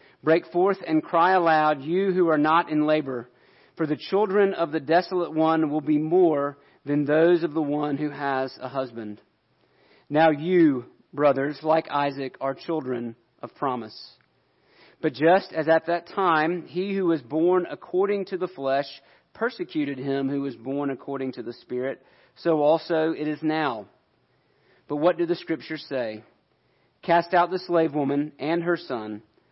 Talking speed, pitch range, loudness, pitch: 165 wpm, 140-170 Hz, -24 LUFS, 155 Hz